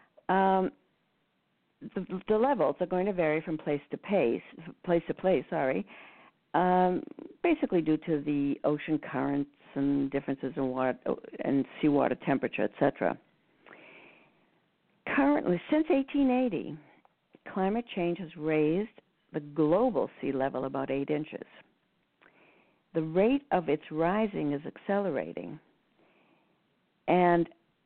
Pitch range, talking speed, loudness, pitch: 150-215 Hz, 115 wpm, -30 LUFS, 170 Hz